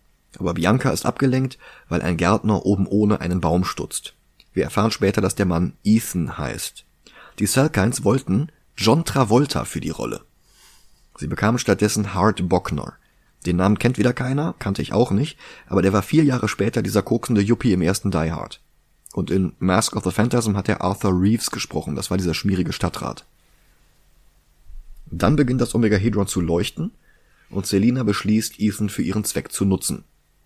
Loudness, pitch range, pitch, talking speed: -21 LUFS, 90-115 Hz, 100 Hz, 170 wpm